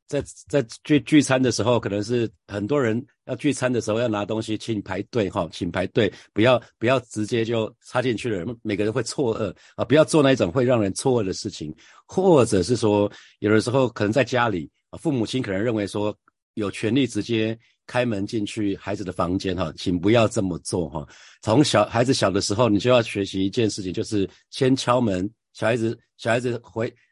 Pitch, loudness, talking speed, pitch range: 110 Hz, -23 LUFS, 300 characters per minute, 105-125 Hz